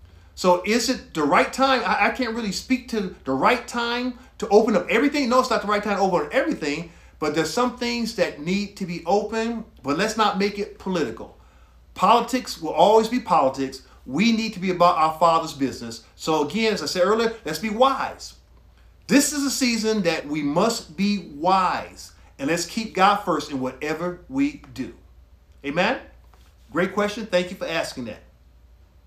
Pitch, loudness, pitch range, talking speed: 205 Hz, -22 LUFS, 165-230 Hz, 190 wpm